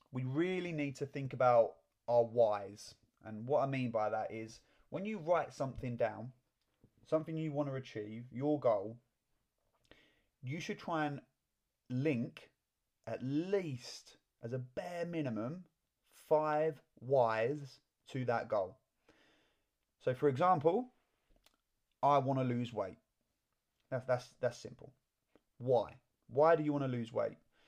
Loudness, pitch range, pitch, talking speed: -36 LUFS, 115-150 Hz, 130 Hz, 135 wpm